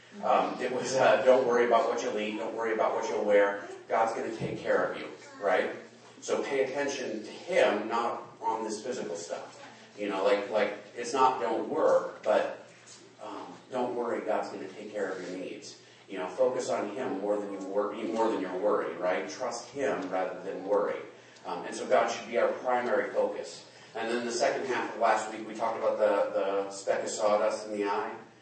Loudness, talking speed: -30 LUFS, 215 wpm